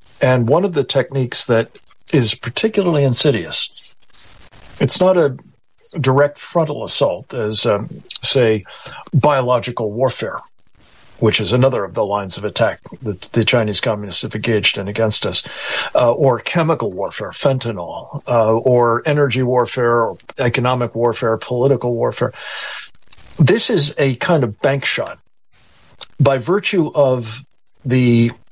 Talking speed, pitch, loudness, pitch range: 130 wpm, 125 Hz, -17 LUFS, 115-140 Hz